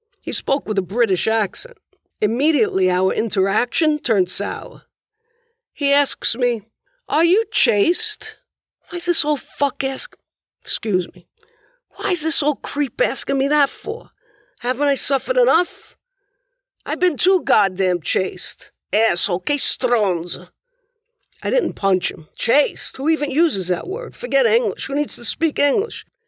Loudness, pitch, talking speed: -19 LUFS, 295 Hz, 145 wpm